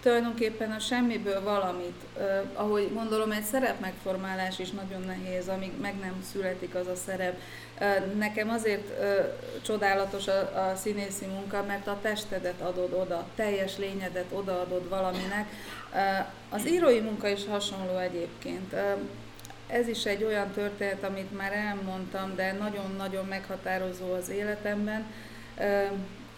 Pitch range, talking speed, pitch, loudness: 185-210 Hz, 135 wpm, 195 Hz, -31 LUFS